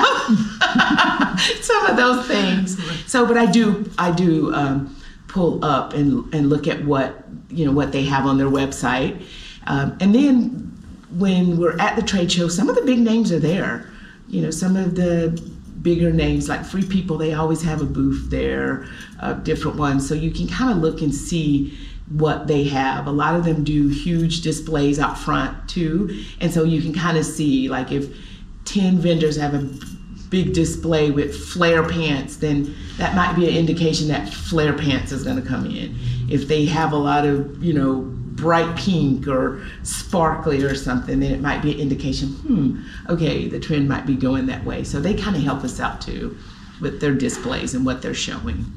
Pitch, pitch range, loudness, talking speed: 155 Hz, 140-175 Hz, -20 LUFS, 195 wpm